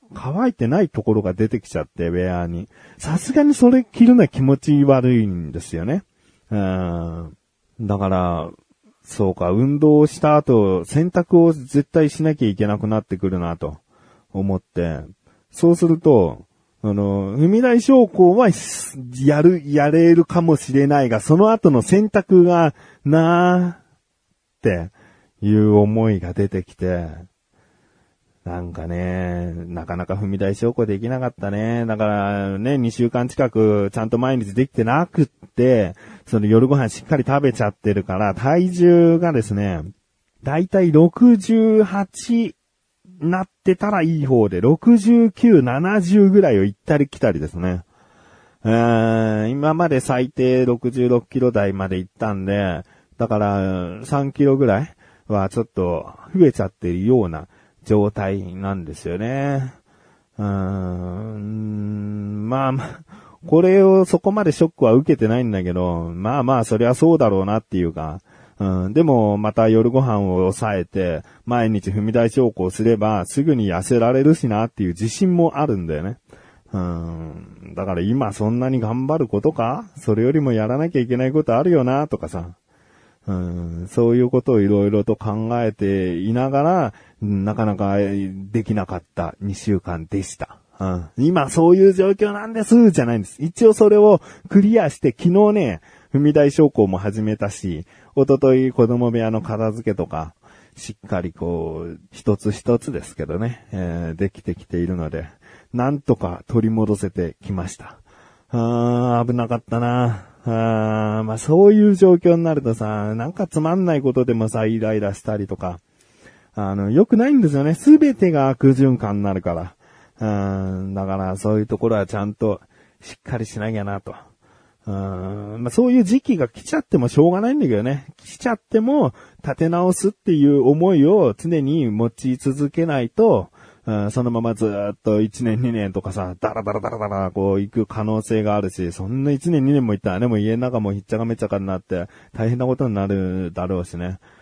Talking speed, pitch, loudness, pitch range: 310 characters per minute, 115 Hz, -18 LUFS, 100-145 Hz